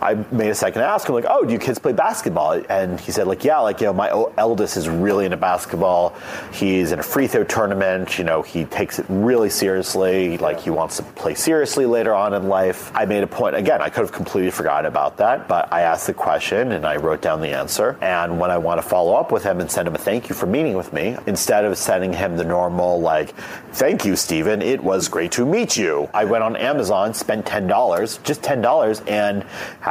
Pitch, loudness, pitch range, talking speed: 95 Hz, -19 LUFS, 90-100 Hz, 240 wpm